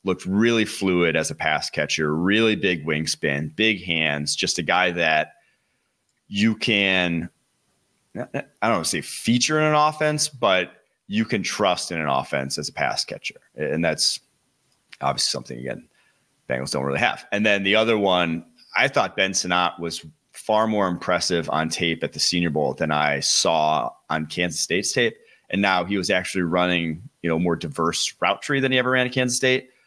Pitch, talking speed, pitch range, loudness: 90 Hz, 185 wpm, 80-115 Hz, -22 LUFS